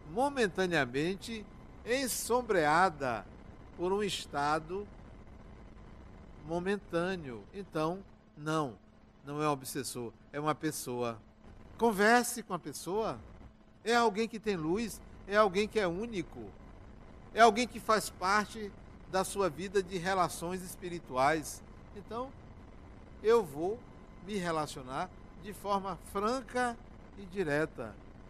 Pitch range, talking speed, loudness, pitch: 150-215 Hz, 105 wpm, -33 LUFS, 185 Hz